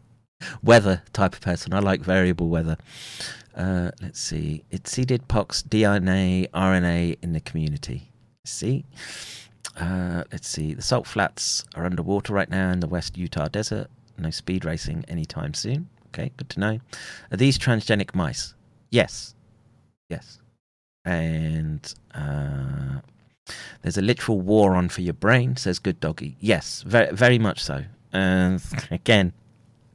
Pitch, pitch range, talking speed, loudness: 95 Hz, 85-115 Hz, 140 wpm, -24 LUFS